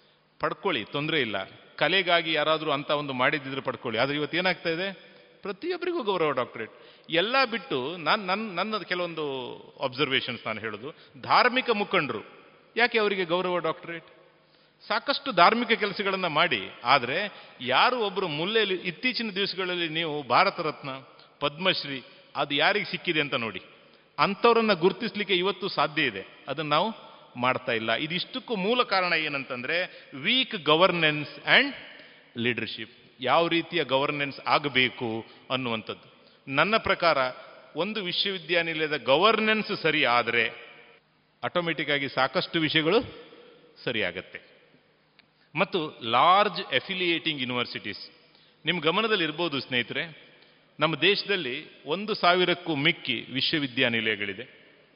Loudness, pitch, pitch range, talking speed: -26 LUFS, 170 Hz, 145-200 Hz, 105 wpm